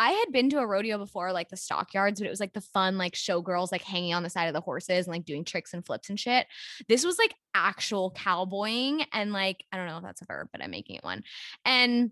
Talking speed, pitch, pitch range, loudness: 265 wpm, 195 Hz, 180-225 Hz, -29 LUFS